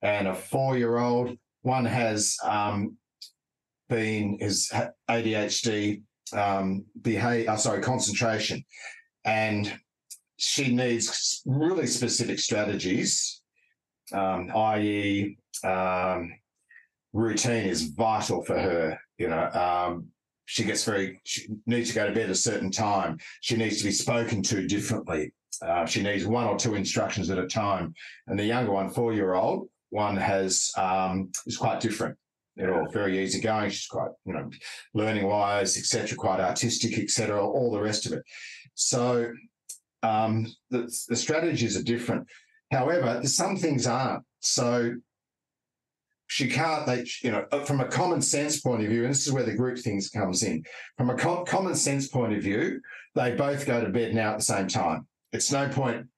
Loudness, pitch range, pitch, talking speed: -27 LUFS, 100-125 Hz, 115 Hz, 160 wpm